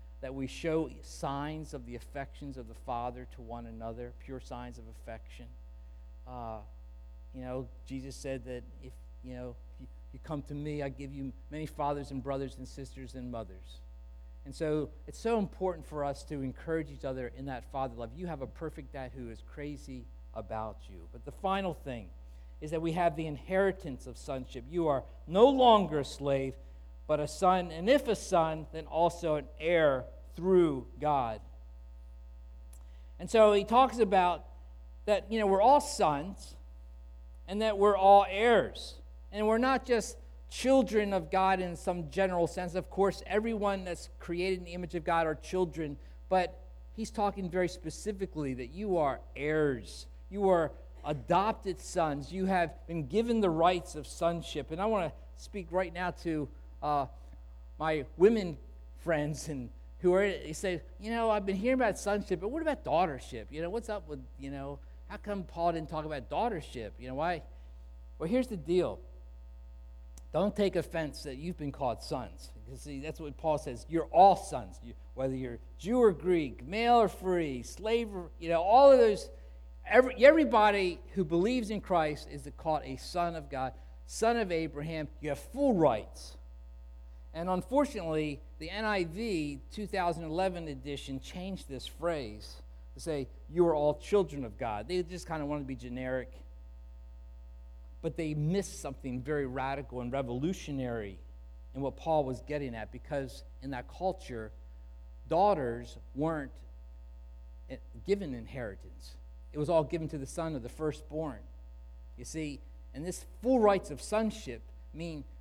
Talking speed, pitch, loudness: 170 wpm, 145 Hz, -32 LUFS